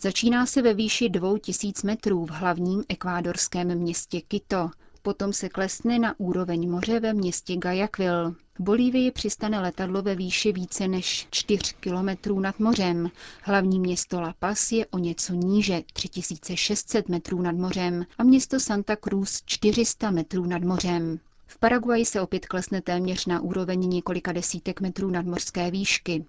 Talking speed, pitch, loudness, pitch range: 150 wpm, 185 Hz, -26 LUFS, 180-210 Hz